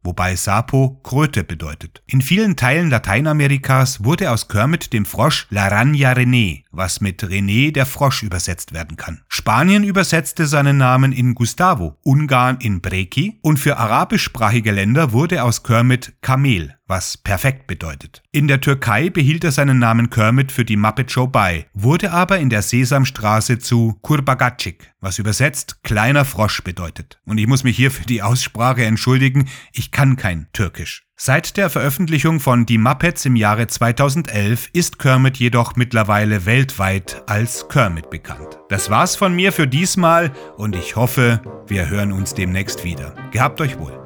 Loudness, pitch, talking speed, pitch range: -16 LUFS, 125 Hz, 155 wpm, 105-140 Hz